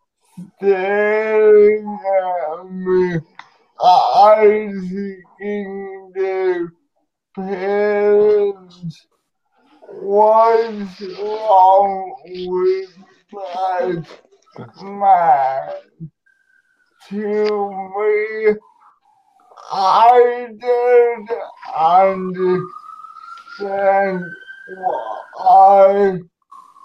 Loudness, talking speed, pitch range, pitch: -15 LUFS, 40 wpm, 190-240 Hz, 205 Hz